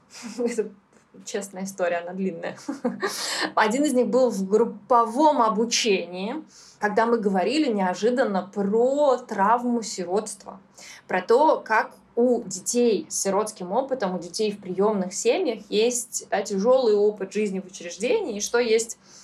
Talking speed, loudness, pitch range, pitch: 130 wpm, -24 LUFS, 195-240 Hz, 220 Hz